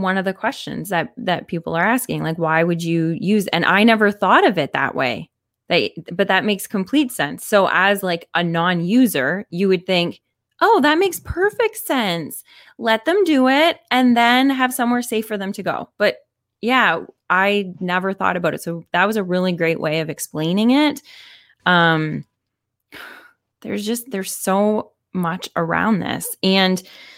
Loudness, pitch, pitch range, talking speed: -18 LUFS, 195 Hz, 175-250 Hz, 175 wpm